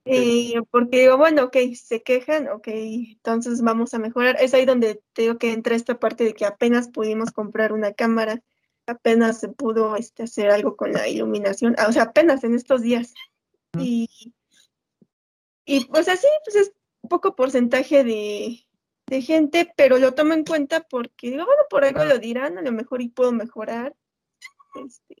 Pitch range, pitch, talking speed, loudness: 225-275 Hz, 245 Hz, 170 wpm, -20 LUFS